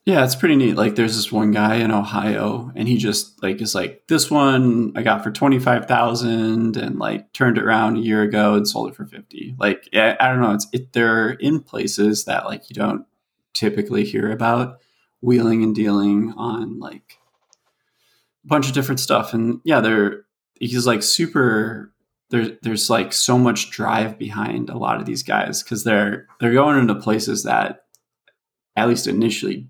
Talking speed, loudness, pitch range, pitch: 185 wpm, -19 LUFS, 105-125 Hz, 115 Hz